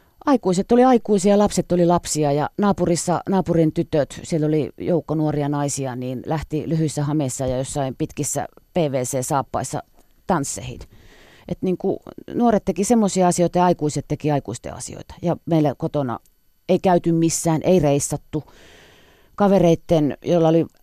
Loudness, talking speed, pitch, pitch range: -20 LUFS, 135 wpm, 160 Hz, 145-180 Hz